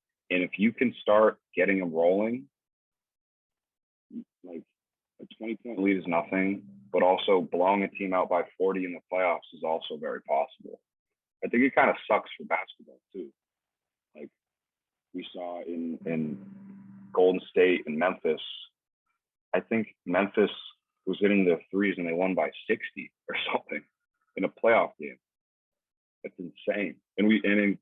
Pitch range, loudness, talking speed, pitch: 90-110 Hz, -28 LUFS, 155 wpm, 95 Hz